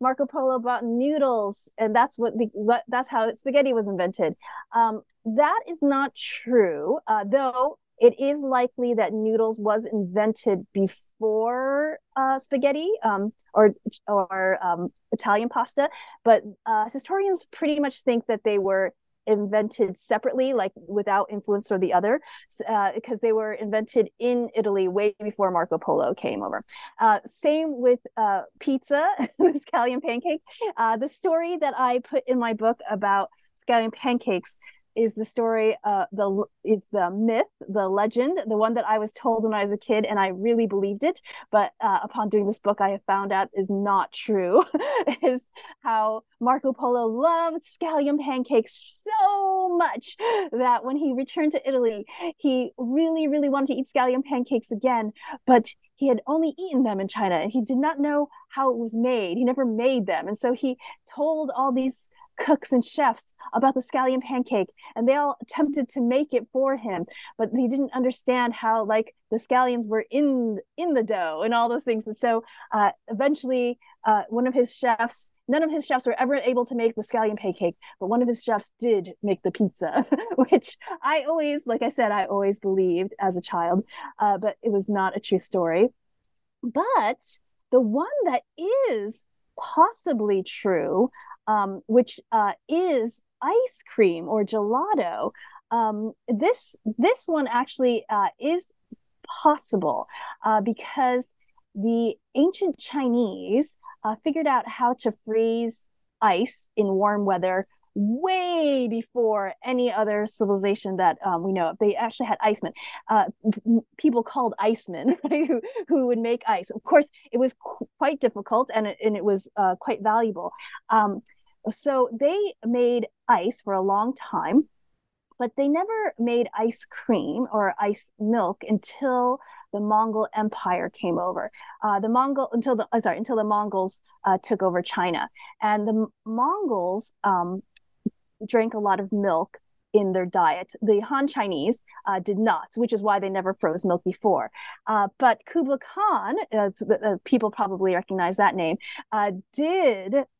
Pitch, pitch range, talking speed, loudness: 235 Hz, 210-275 Hz, 160 wpm, -24 LUFS